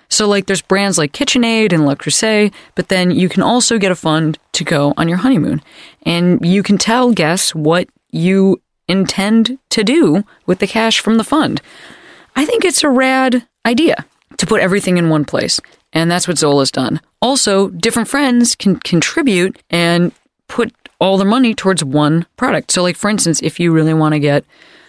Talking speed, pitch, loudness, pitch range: 190 wpm, 195 Hz, -13 LUFS, 170-235 Hz